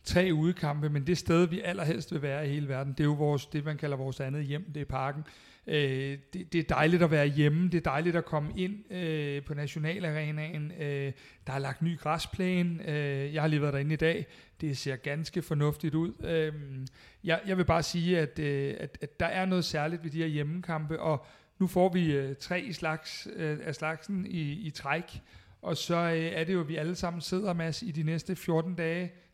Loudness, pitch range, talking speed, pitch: -31 LUFS, 145-170 Hz, 225 wpm, 155 Hz